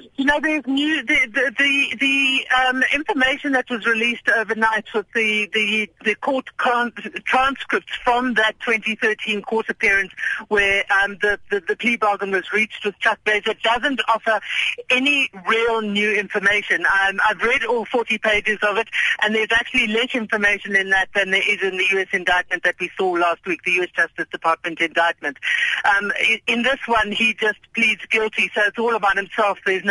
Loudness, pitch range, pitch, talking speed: -19 LUFS, 200-245 Hz, 220 Hz, 180 wpm